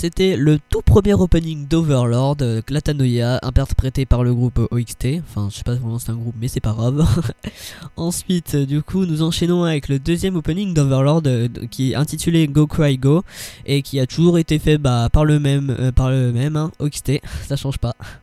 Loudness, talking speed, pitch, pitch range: -18 LUFS, 195 wpm, 135 Hz, 120-155 Hz